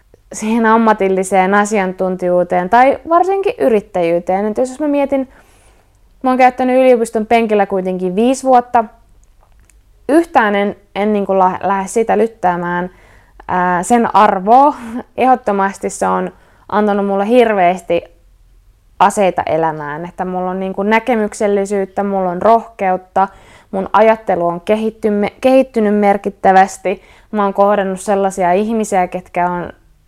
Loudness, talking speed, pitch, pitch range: -14 LUFS, 120 wpm, 200 Hz, 180-225 Hz